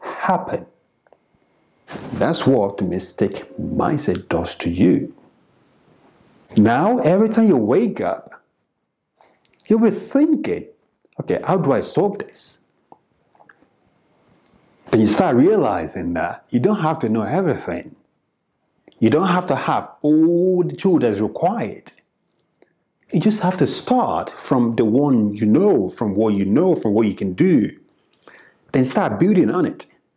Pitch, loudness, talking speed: 170 Hz, -18 LUFS, 140 wpm